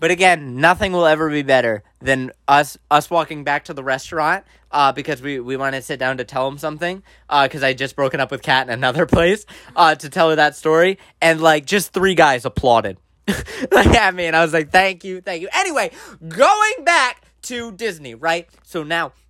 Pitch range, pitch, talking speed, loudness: 135-180 Hz, 160 Hz, 215 wpm, -17 LUFS